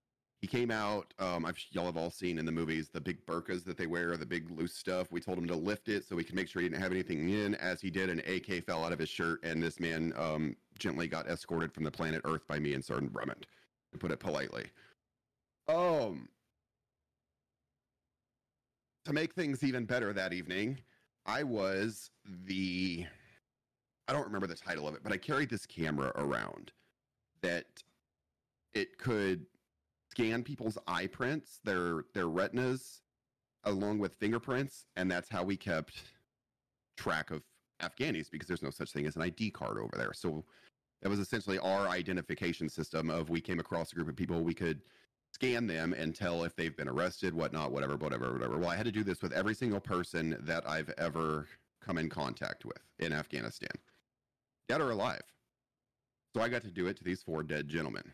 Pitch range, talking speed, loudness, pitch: 80-105 Hz, 190 wpm, -37 LUFS, 90 Hz